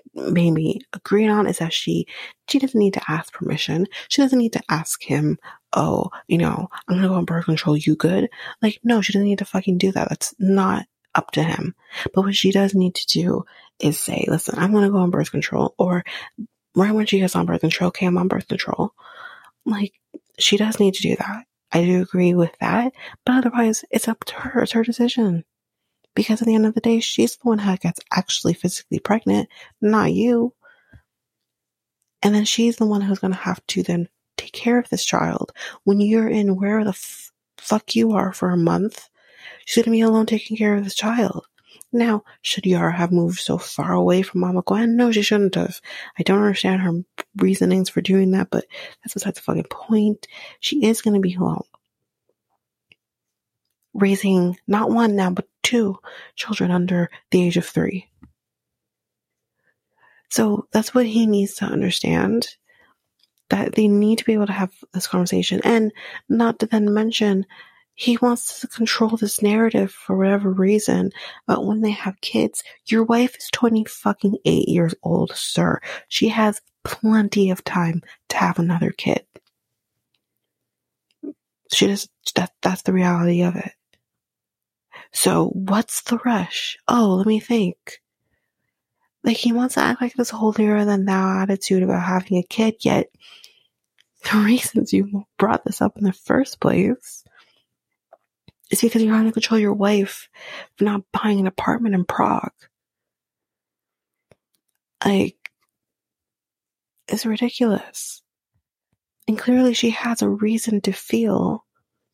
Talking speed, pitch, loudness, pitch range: 170 wpm, 205 Hz, -20 LUFS, 185-225 Hz